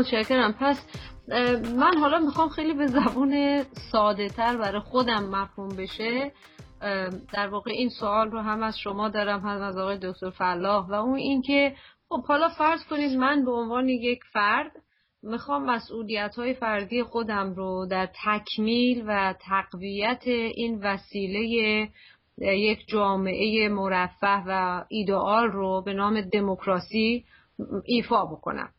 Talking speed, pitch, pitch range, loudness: 135 wpm, 215 Hz, 200-245 Hz, -26 LUFS